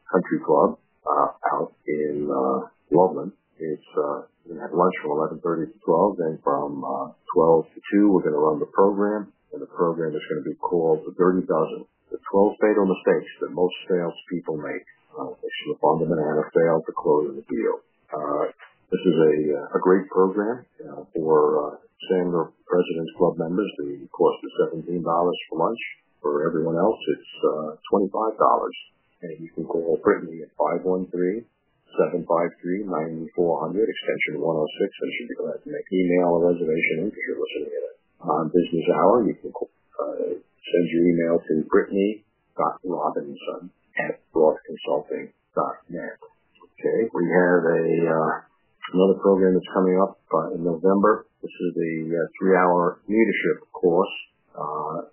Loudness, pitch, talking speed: -23 LUFS, 95 Hz, 155 wpm